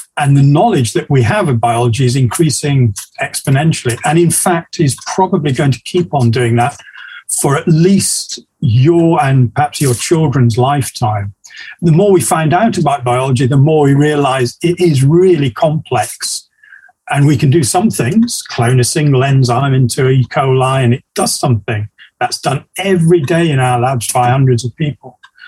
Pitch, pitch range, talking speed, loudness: 140 Hz, 125-165 Hz, 175 wpm, -12 LUFS